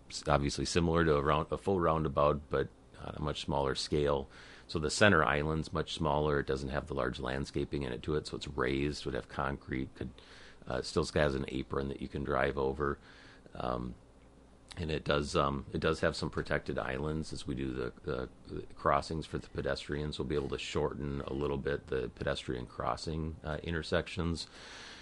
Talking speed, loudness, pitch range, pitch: 195 wpm, -34 LUFS, 65-80 Hz, 75 Hz